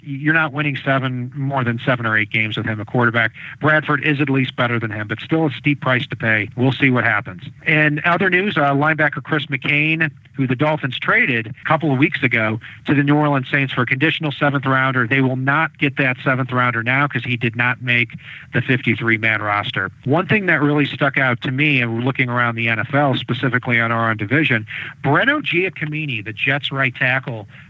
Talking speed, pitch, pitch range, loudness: 215 wpm, 135 Hz, 120-145 Hz, -18 LUFS